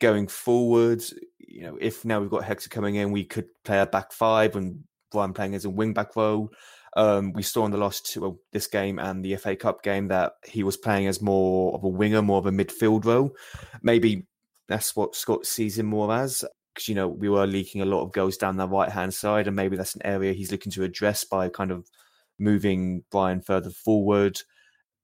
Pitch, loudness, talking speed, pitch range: 100 Hz, -25 LUFS, 220 wpm, 95-110 Hz